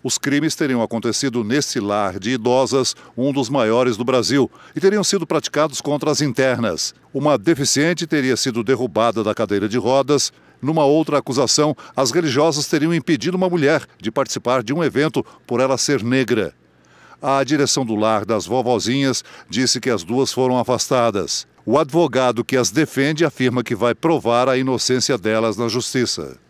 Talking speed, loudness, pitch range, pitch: 165 wpm, -18 LUFS, 120-145 Hz, 130 Hz